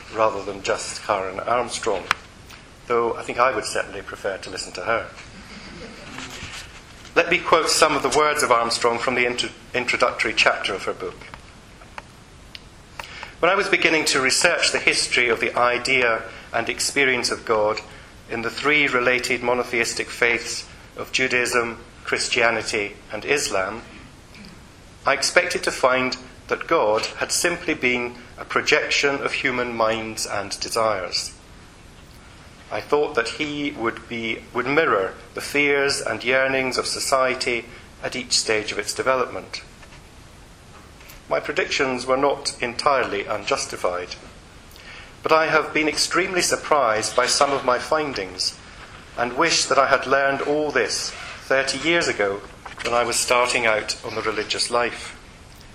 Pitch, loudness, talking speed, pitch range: 125 Hz, -21 LUFS, 140 wpm, 115-140 Hz